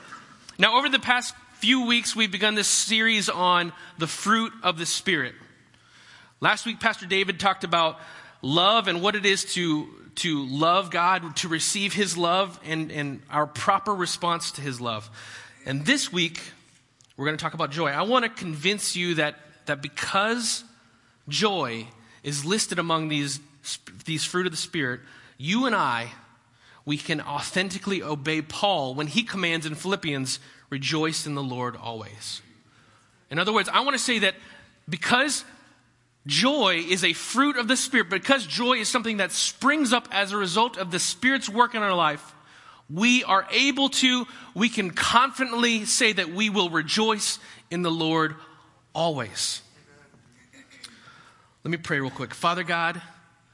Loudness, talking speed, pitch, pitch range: -24 LUFS, 160 wpm, 175 Hz, 150-215 Hz